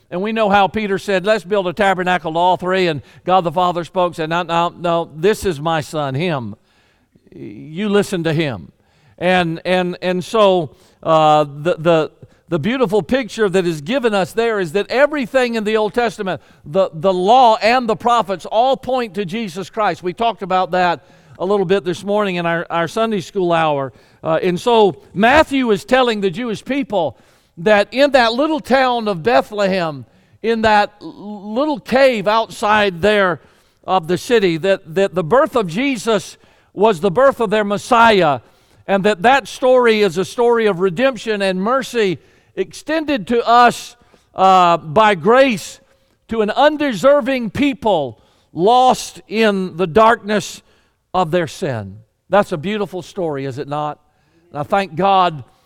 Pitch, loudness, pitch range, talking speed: 195 Hz, -16 LUFS, 175-230 Hz, 165 wpm